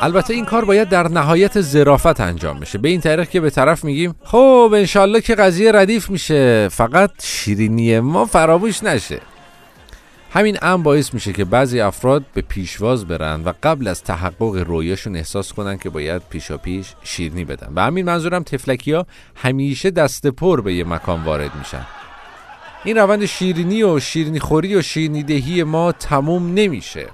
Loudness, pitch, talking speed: -16 LUFS, 145 Hz, 165 wpm